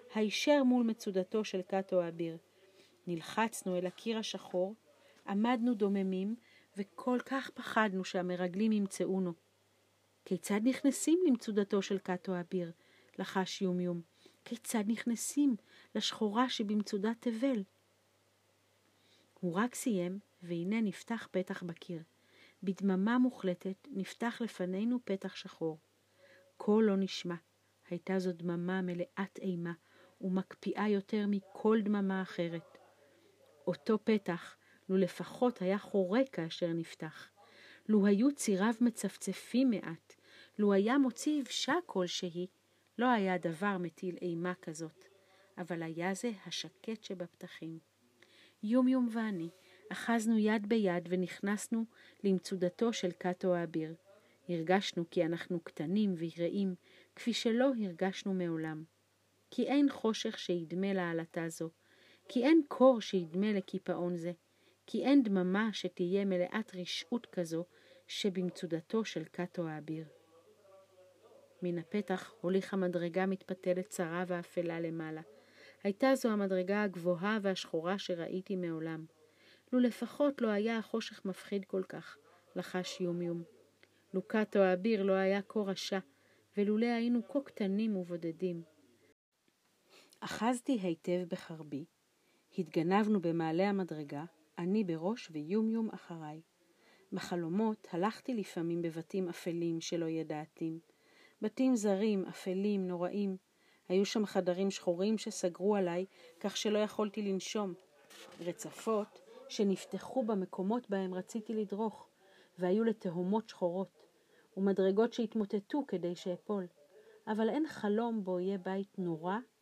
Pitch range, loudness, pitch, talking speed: 175-215 Hz, -35 LUFS, 190 Hz, 110 wpm